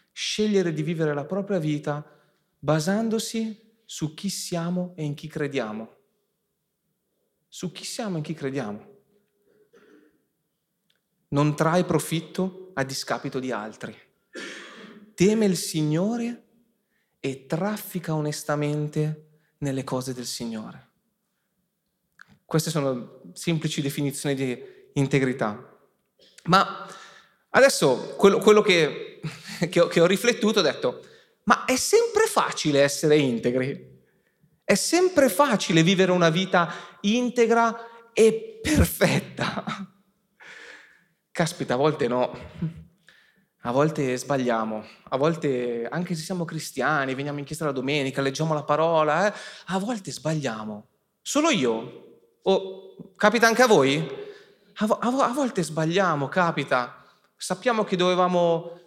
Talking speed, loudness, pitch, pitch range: 115 wpm, -24 LUFS, 175 Hz, 145-205 Hz